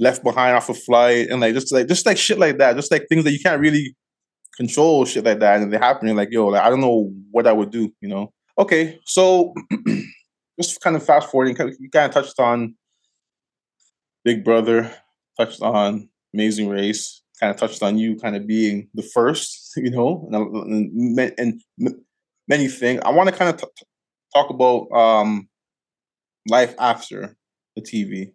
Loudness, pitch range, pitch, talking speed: -18 LUFS, 110-145 Hz, 120 Hz, 190 wpm